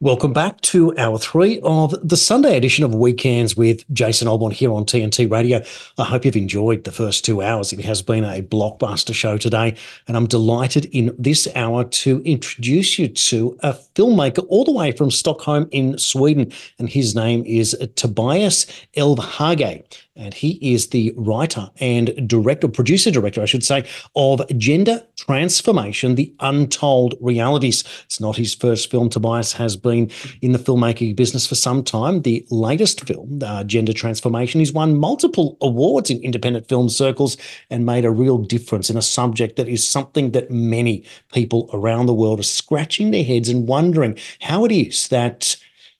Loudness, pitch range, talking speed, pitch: -17 LUFS, 115-145 Hz, 170 wpm, 125 Hz